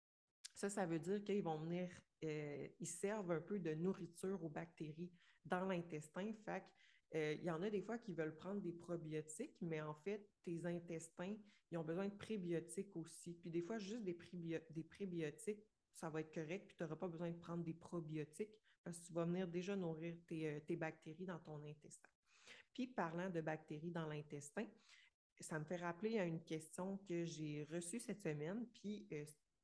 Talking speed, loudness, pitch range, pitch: 195 wpm, -48 LUFS, 160-195 Hz, 175 Hz